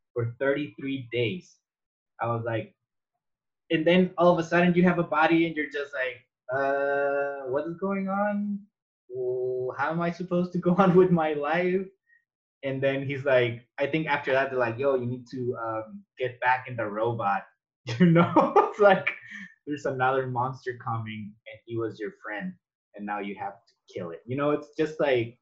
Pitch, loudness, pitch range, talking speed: 140 Hz, -26 LUFS, 125-170 Hz, 190 wpm